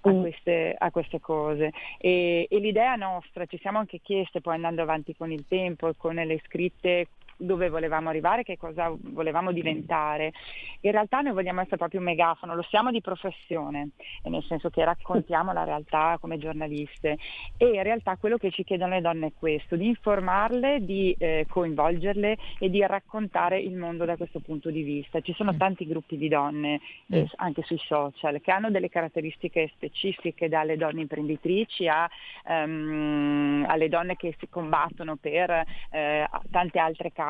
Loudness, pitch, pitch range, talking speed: -27 LUFS, 170 Hz, 160-185 Hz, 170 wpm